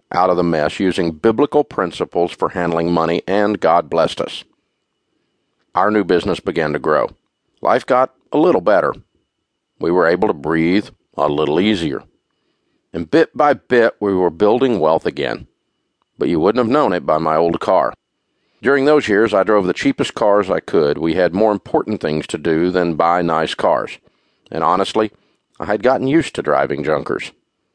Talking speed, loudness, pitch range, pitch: 175 wpm, -16 LUFS, 85-105 Hz, 90 Hz